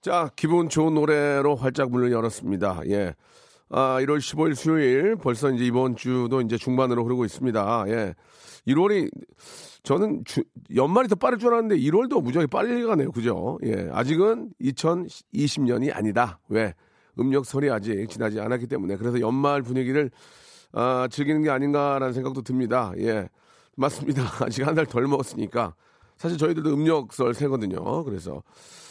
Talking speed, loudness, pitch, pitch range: 325 characters per minute, -24 LUFS, 130 Hz, 120-150 Hz